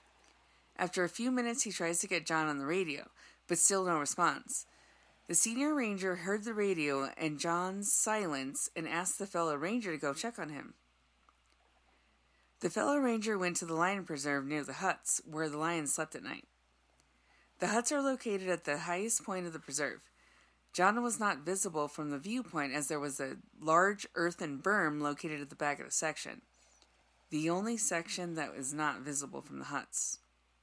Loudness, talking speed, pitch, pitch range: -34 LUFS, 185 wpm, 165 Hz, 145-195 Hz